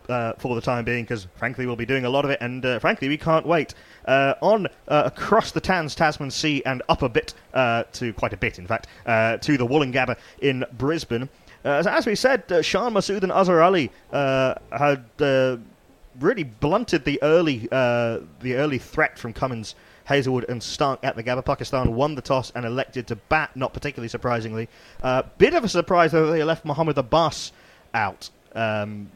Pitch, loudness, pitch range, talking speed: 135 Hz, -23 LUFS, 120-155 Hz, 205 wpm